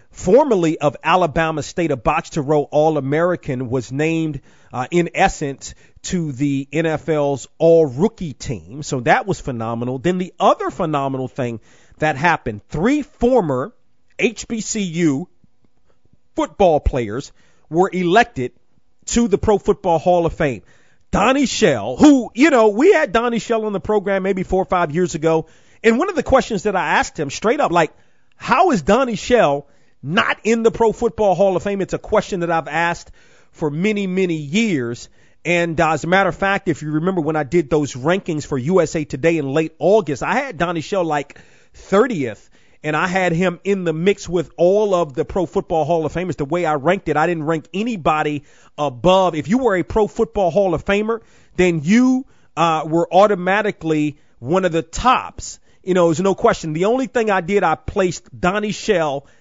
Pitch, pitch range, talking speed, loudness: 175 Hz, 155-200 Hz, 185 wpm, -18 LUFS